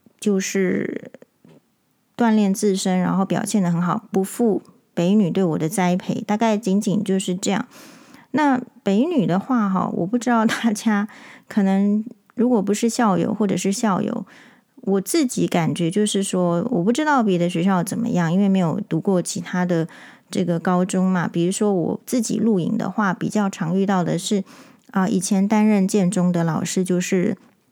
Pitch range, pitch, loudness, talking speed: 185-230 Hz, 200 Hz, -21 LUFS, 255 characters per minute